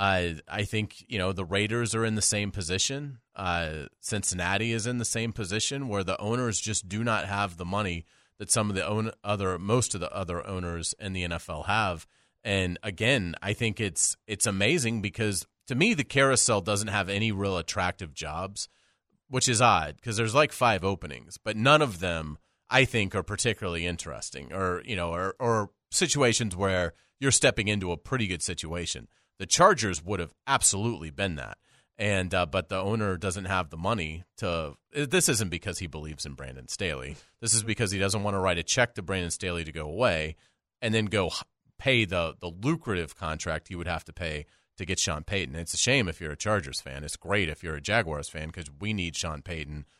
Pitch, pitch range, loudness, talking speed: 100 Hz, 85-110 Hz, -28 LUFS, 205 wpm